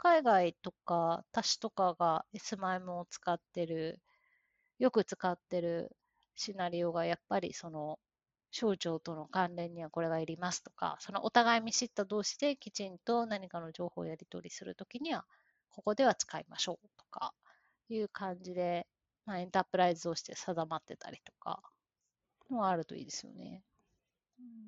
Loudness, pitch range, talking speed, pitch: -36 LUFS, 170-225 Hz, 320 characters per minute, 185 Hz